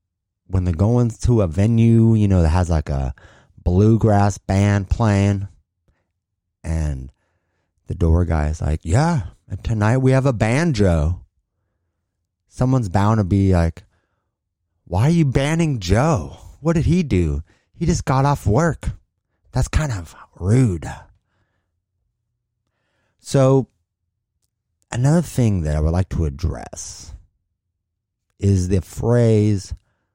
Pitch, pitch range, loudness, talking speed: 100 Hz, 90-115 Hz, -19 LUFS, 125 wpm